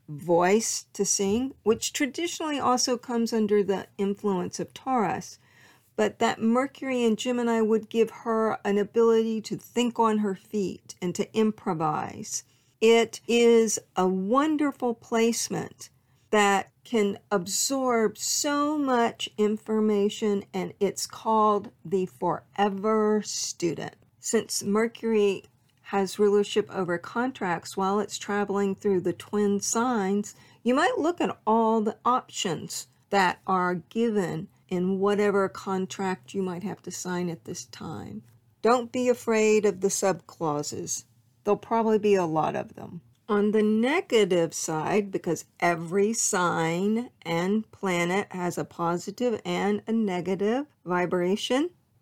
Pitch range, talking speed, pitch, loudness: 185-230 Hz, 125 wpm, 205 Hz, -26 LUFS